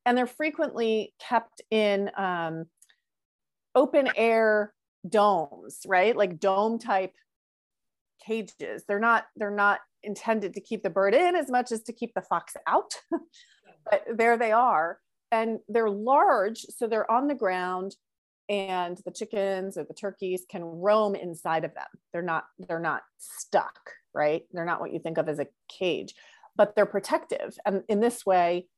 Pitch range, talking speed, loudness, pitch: 185-230 Hz, 160 wpm, -27 LUFS, 205 Hz